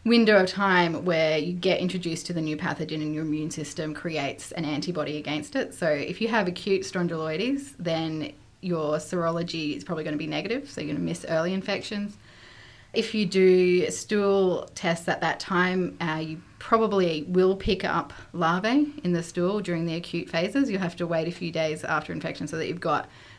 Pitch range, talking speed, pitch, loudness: 155-190 Hz, 200 wpm, 170 Hz, -26 LUFS